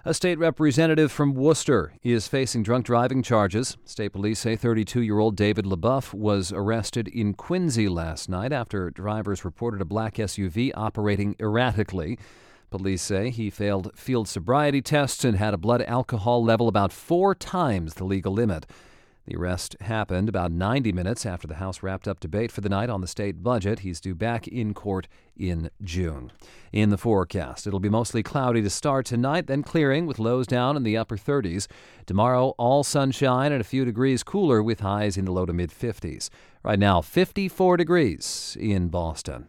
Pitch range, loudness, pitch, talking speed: 100-130 Hz, -25 LUFS, 110 Hz, 180 wpm